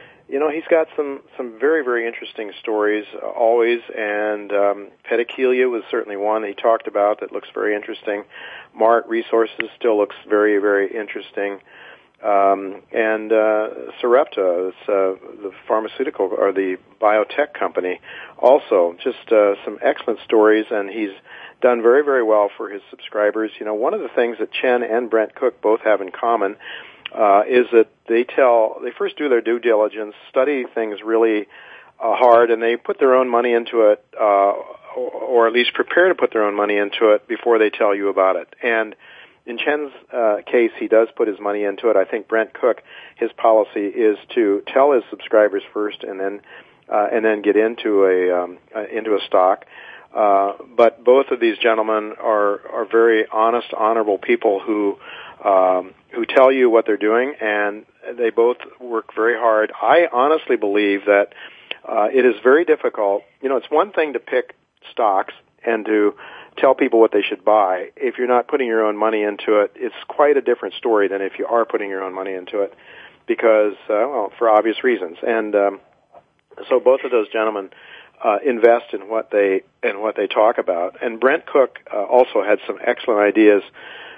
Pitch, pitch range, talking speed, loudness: 110 Hz, 105-120 Hz, 185 wpm, -18 LUFS